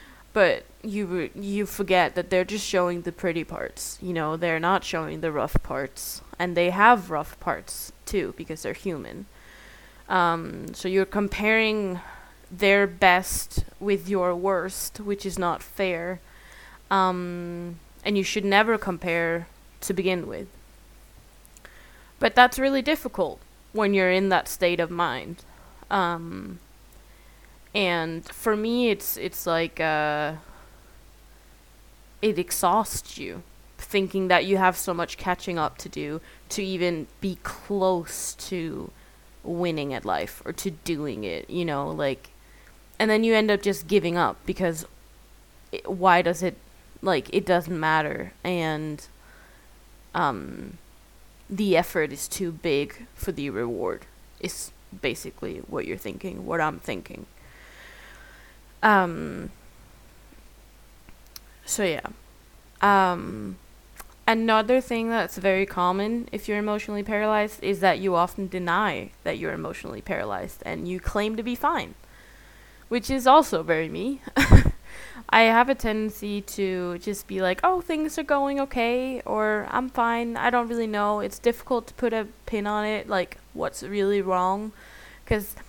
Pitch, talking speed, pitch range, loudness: 190 Hz, 140 wpm, 175-215 Hz, -25 LUFS